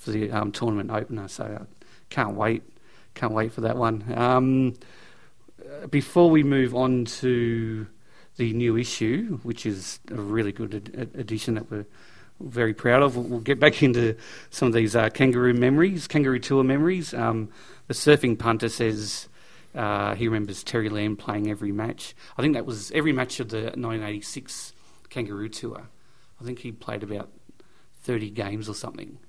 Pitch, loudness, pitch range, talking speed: 115 Hz, -25 LUFS, 110-125 Hz, 170 wpm